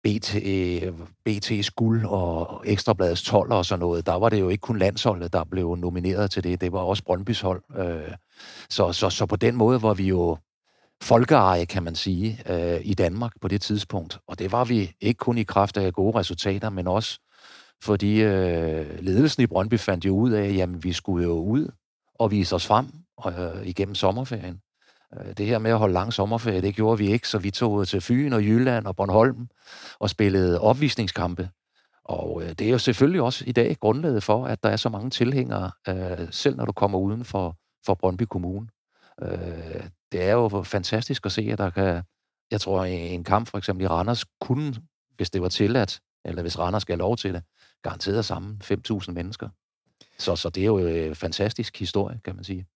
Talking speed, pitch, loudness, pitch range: 195 wpm, 100 Hz, -24 LUFS, 90-110 Hz